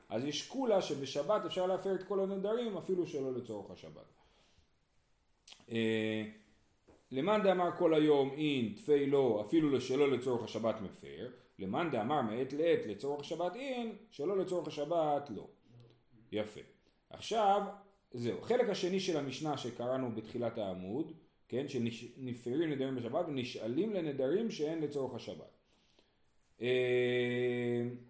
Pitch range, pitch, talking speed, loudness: 120-185 Hz, 140 Hz, 115 wpm, -35 LUFS